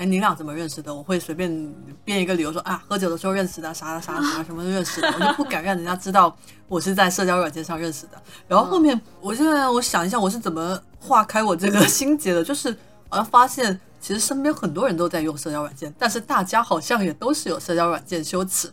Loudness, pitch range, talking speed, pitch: -22 LUFS, 165-215 Hz, 375 characters per minute, 185 Hz